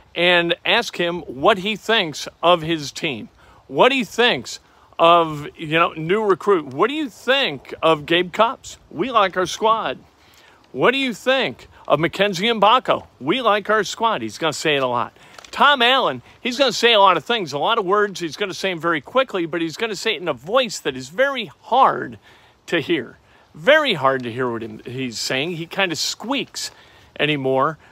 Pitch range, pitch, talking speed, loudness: 165-230 Hz, 190 Hz, 195 wpm, -19 LUFS